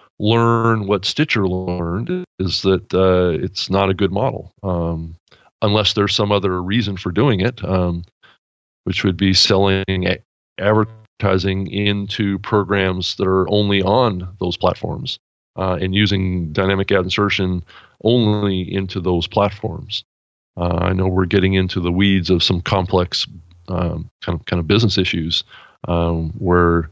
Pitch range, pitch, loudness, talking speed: 90-105 Hz, 95 Hz, -18 LUFS, 145 wpm